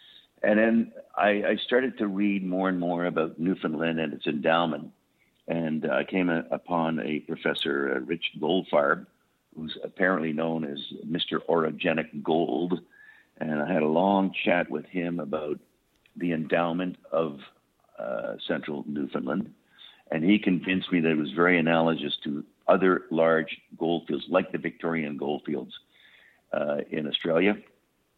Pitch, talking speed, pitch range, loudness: 85 Hz, 150 wpm, 80-95 Hz, -27 LUFS